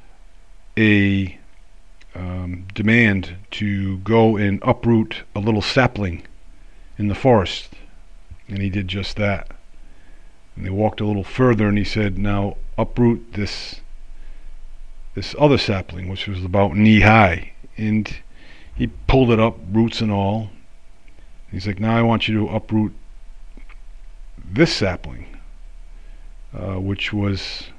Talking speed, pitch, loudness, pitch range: 125 wpm, 100 Hz, -19 LUFS, 95-110 Hz